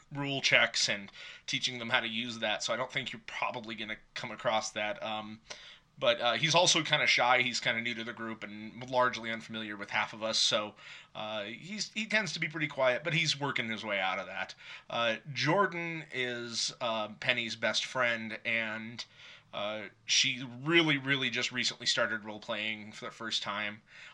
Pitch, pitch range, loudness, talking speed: 120 Hz, 110-140 Hz, -31 LUFS, 195 wpm